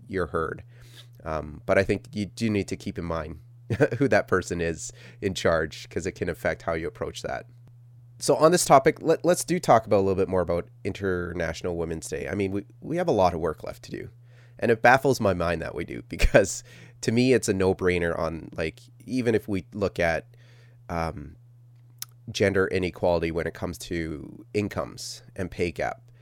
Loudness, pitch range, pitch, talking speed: -26 LUFS, 85-120 Hz, 100 Hz, 205 wpm